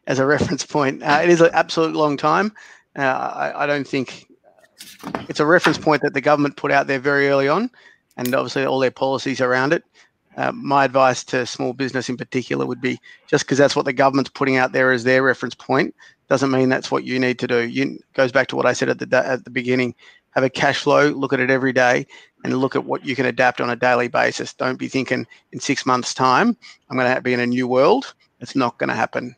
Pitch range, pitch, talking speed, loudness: 125-145 Hz, 135 Hz, 245 wpm, -19 LUFS